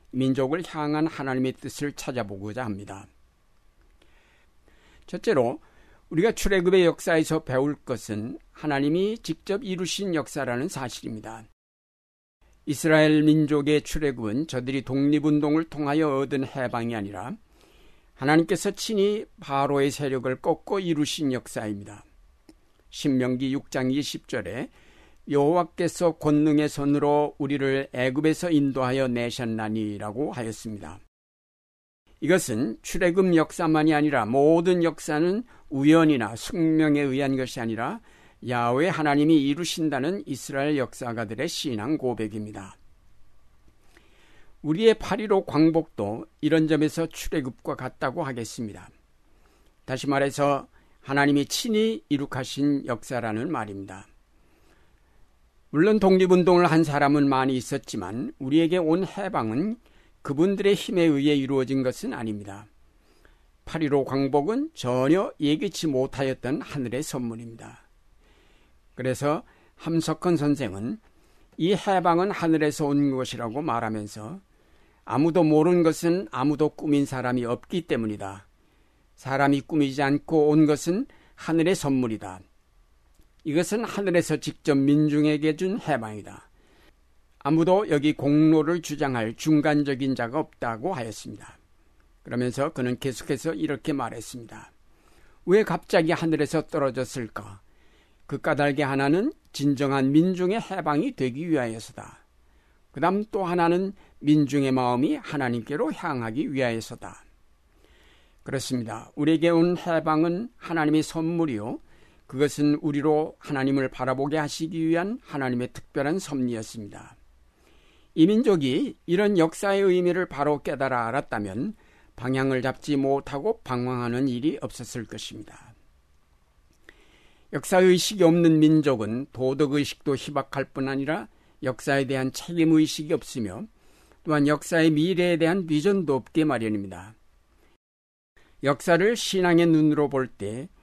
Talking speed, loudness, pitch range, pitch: 285 characters per minute, -25 LUFS, 120-160 Hz, 140 Hz